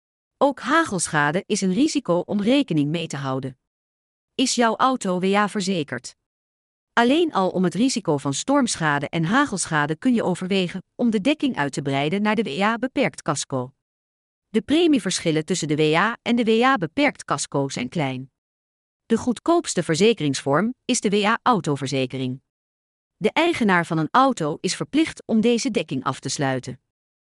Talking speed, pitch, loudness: 145 wpm, 180 Hz, -22 LUFS